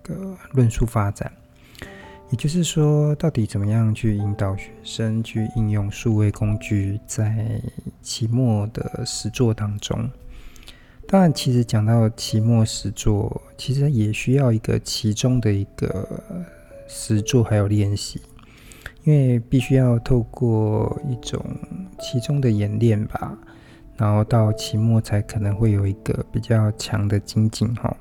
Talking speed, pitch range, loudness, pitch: 205 characters per minute, 110-130 Hz, -21 LUFS, 115 Hz